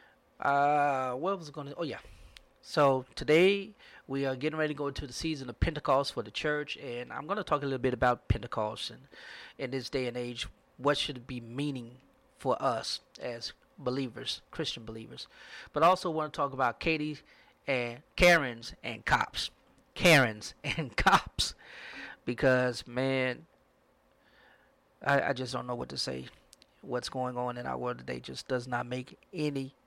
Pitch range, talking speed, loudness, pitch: 120-150 Hz, 170 wpm, -31 LUFS, 135 Hz